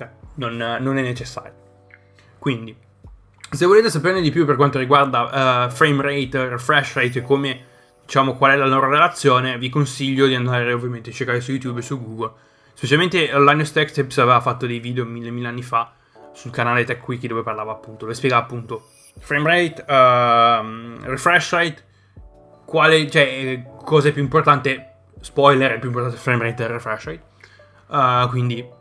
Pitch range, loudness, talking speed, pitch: 115-140 Hz, -18 LUFS, 170 wpm, 125 Hz